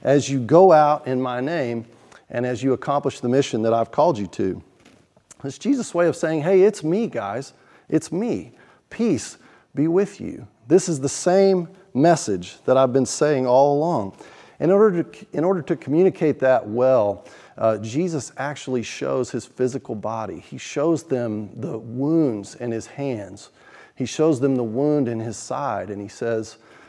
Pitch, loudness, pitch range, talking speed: 135 Hz, -21 LUFS, 120-160 Hz, 175 wpm